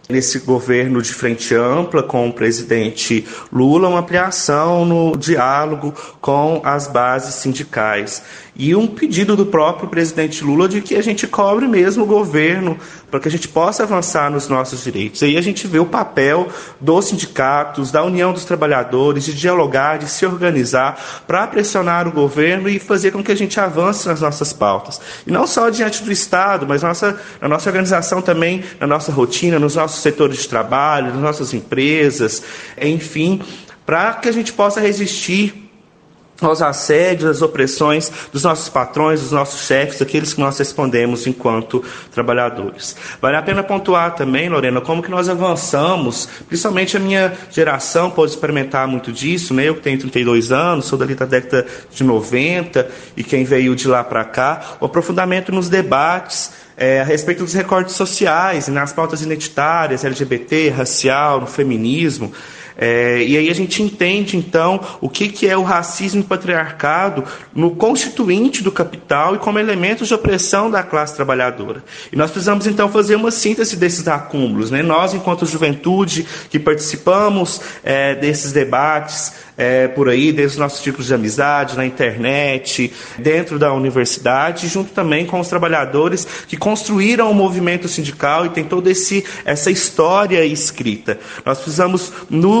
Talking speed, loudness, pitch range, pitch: 160 wpm, -16 LUFS, 140-185 Hz, 160 Hz